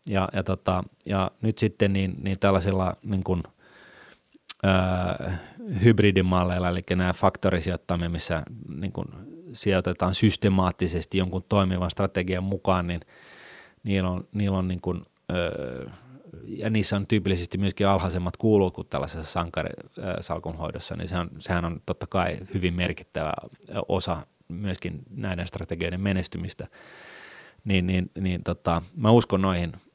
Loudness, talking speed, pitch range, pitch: -26 LUFS, 120 wpm, 90-100 Hz, 95 Hz